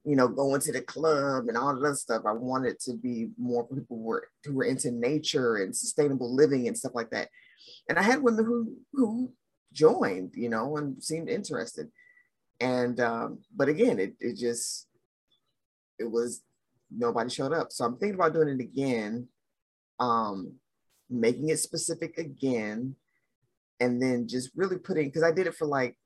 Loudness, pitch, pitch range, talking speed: -29 LUFS, 140 Hz, 120-165 Hz, 175 wpm